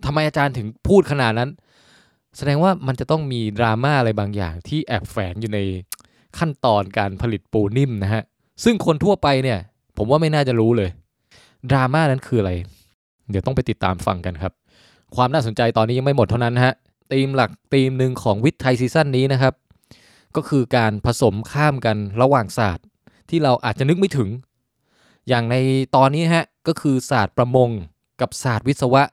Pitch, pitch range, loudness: 125 Hz, 110-140 Hz, -19 LUFS